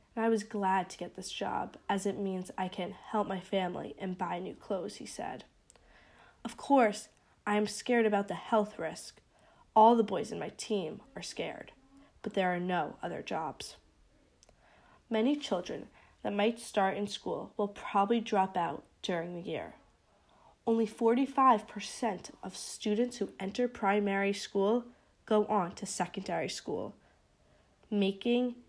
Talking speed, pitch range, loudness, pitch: 155 wpm, 190-225 Hz, -33 LUFS, 205 Hz